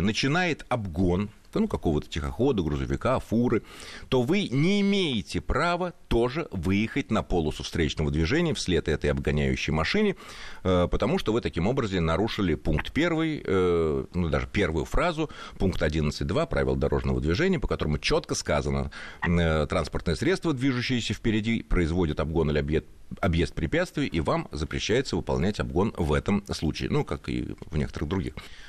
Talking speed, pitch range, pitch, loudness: 145 wpm, 75-115 Hz, 90 Hz, -27 LUFS